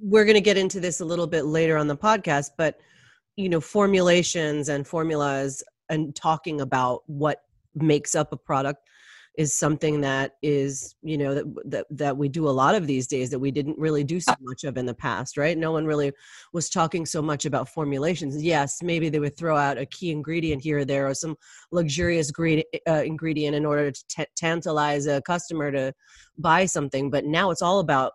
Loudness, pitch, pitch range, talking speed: -24 LUFS, 150 Hz, 140-165 Hz, 205 wpm